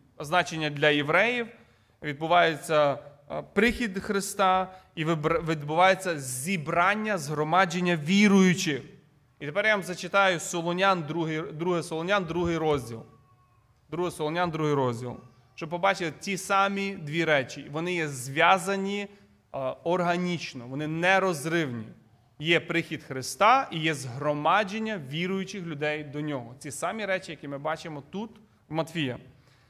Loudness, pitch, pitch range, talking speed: -27 LUFS, 165 Hz, 145-185 Hz, 115 wpm